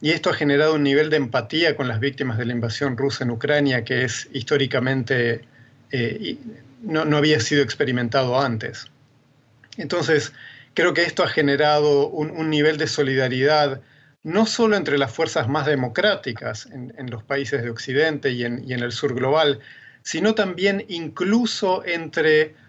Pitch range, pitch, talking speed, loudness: 130-155 Hz, 145 Hz, 165 wpm, -21 LUFS